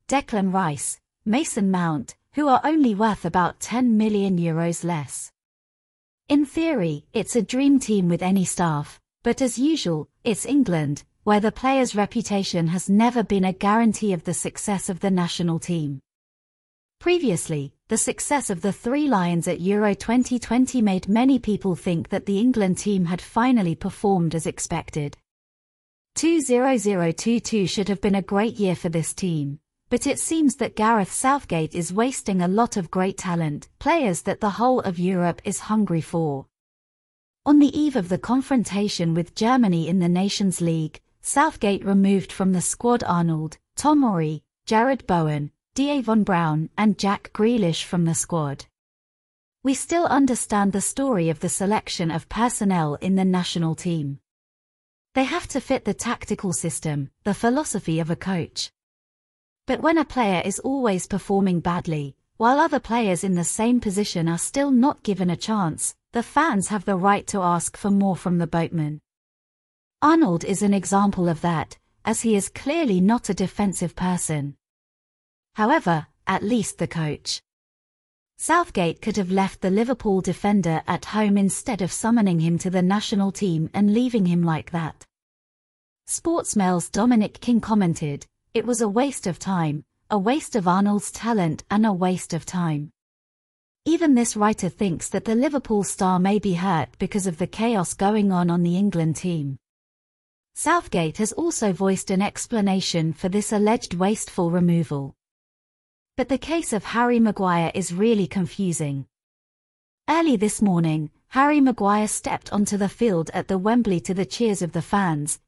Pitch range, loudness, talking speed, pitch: 170-230 Hz, -22 LUFS, 160 wpm, 195 Hz